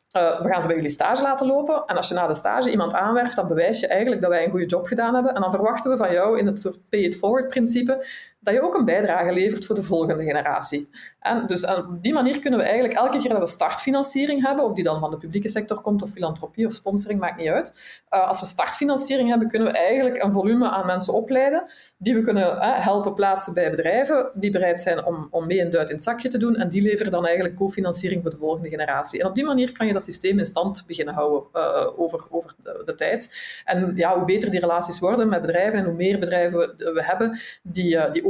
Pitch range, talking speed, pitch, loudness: 175-245 Hz, 250 wpm, 195 Hz, -22 LUFS